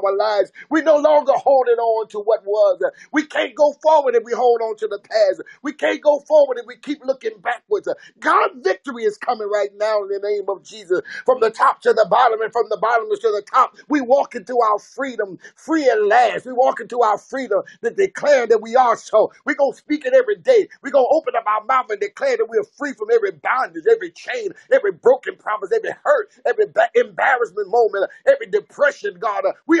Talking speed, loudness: 215 wpm, -18 LUFS